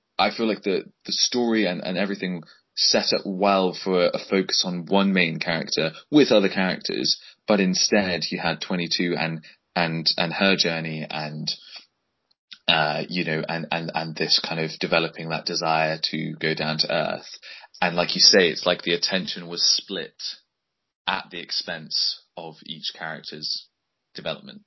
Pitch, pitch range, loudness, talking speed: 85 Hz, 80-95 Hz, -23 LUFS, 165 wpm